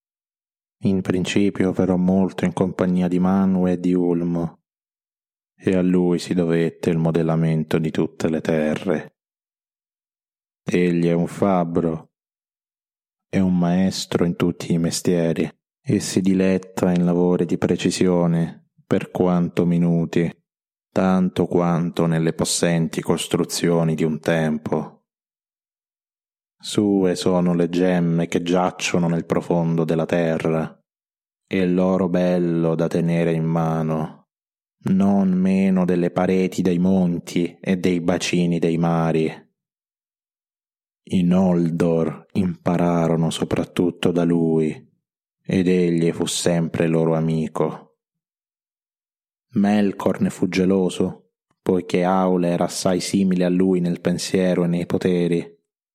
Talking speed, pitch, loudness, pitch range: 115 wpm, 90 Hz, -20 LUFS, 85-95 Hz